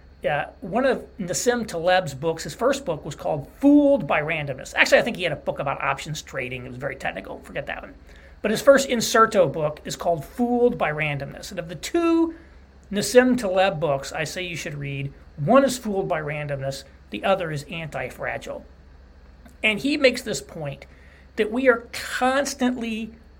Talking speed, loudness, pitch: 185 wpm, -23 LUFS, 185 Hz